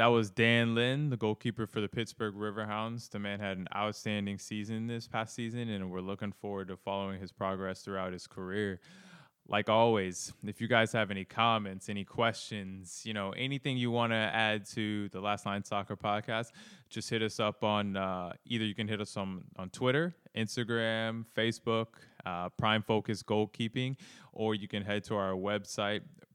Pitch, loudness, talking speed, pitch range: 105 Hz, -34 LUFS, 180 wpm, 100-115 Hz